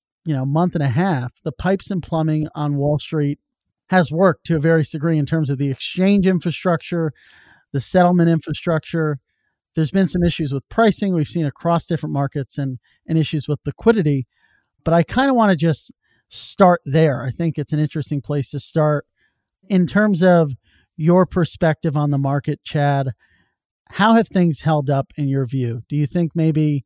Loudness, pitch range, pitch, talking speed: -19 LUFS, 145-175 Hz, 160 Hz, 185 wpm